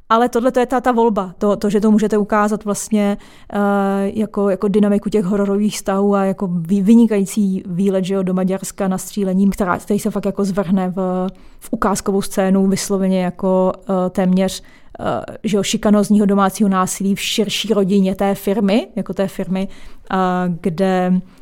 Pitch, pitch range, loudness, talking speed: 200 Hz, 190-210 Hz, -17 LUFS, 165 wpm